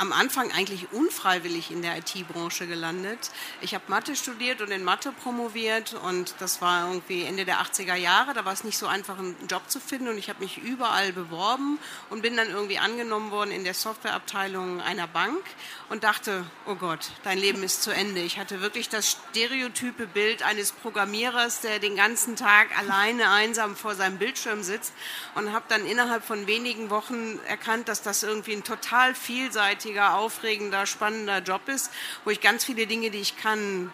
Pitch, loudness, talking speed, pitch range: 210 Hz, -26 LUFS, 185 wpm, 195-225 Hz